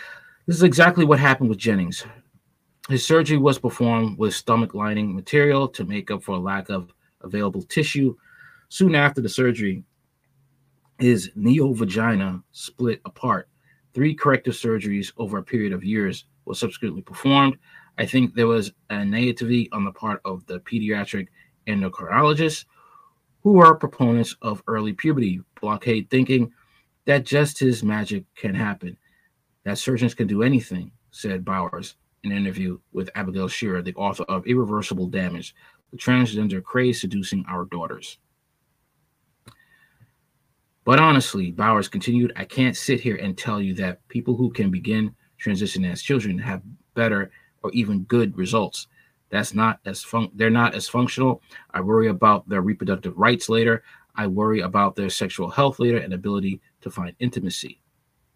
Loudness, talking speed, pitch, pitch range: -22 LUFS, 150 wpm, 115 Hz, 100-135 Hz